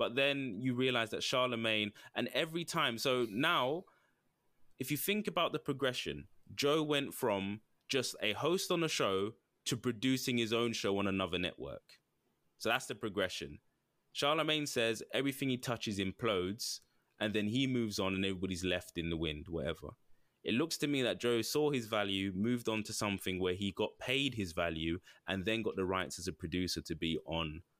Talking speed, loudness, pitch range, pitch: 185 wpm, -35 LUFS, 95-135 Hz, 110 Hz